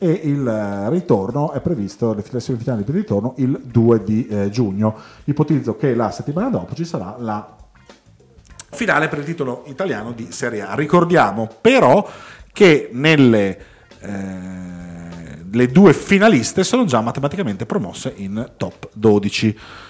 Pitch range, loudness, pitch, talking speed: 105-145 Hz, -17 LUFS, 120 Hz, 135 wpm